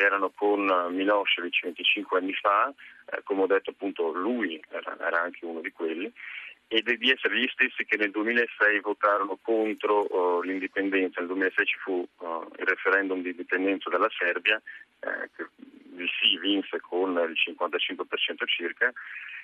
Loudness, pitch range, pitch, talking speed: -26 LUFS, 95-110 Hz, 100 Hz, 155 wpm